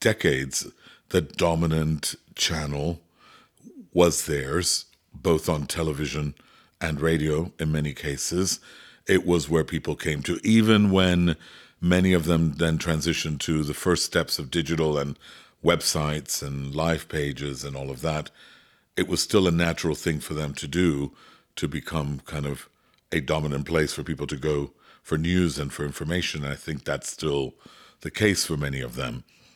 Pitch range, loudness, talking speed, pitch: 75-85 Hz, -25 LUFS, 160 wpm, 80 Hz